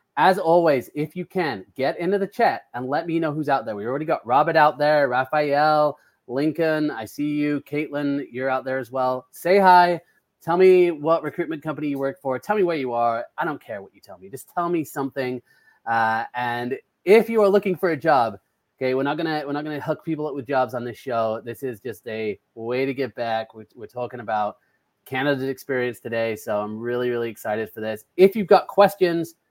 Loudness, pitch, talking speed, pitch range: -22 LUFS, 140 Hz, 220 wpm, 125-165 Hz